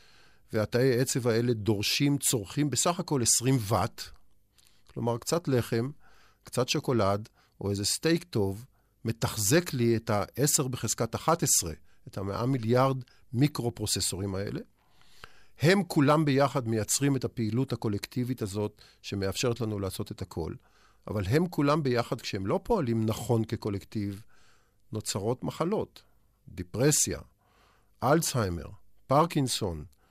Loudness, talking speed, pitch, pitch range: -28 LUFS, 115 wpm, 115 Hz, 105-135 Hz